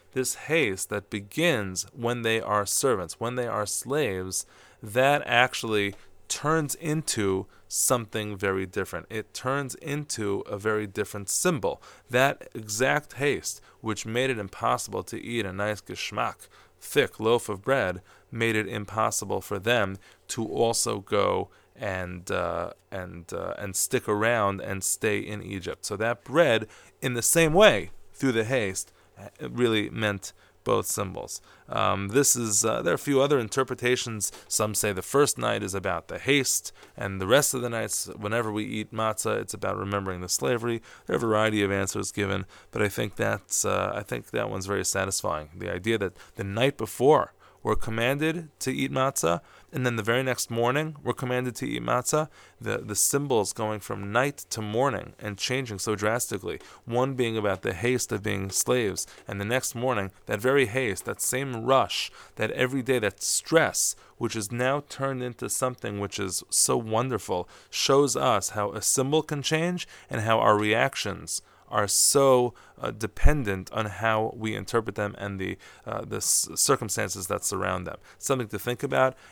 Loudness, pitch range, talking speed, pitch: -27 LUFS, 100-130 Hz, 170 wpm, 110 Hz